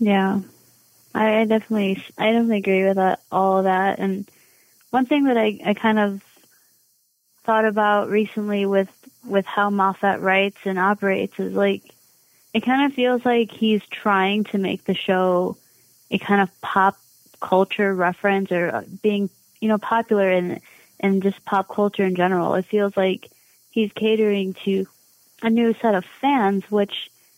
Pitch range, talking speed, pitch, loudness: 190-215 Hz, 160 wpm, 200 Hz, -21 LUFS